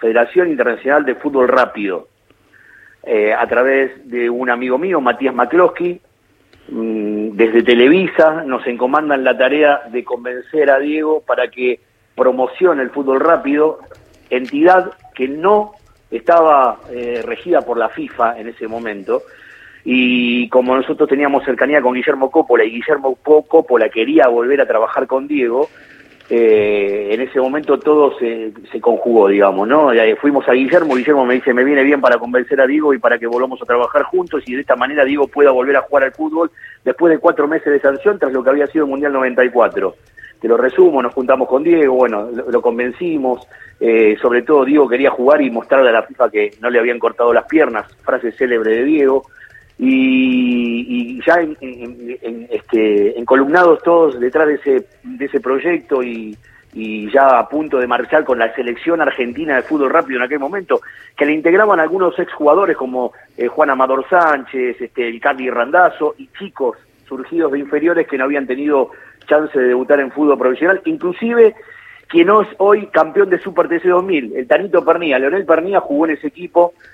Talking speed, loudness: 175 wpm, -14 LUFS